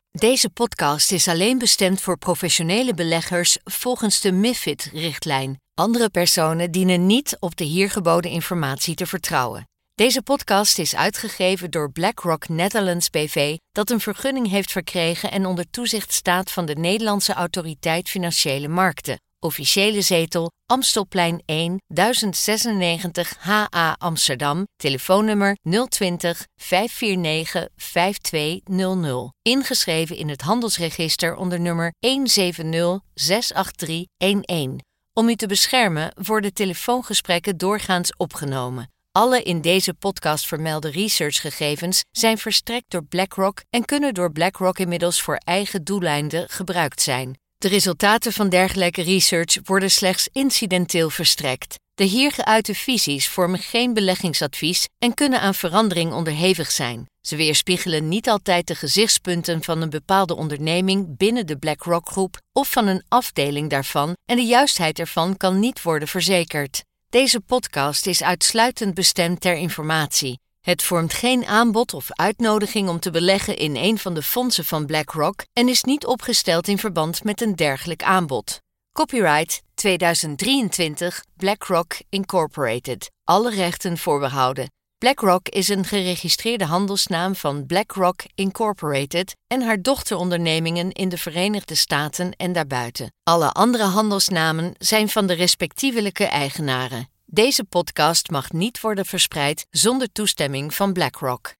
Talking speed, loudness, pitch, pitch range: 125 wpm, -20 LUFS, 180 Hz, 165-205 Hz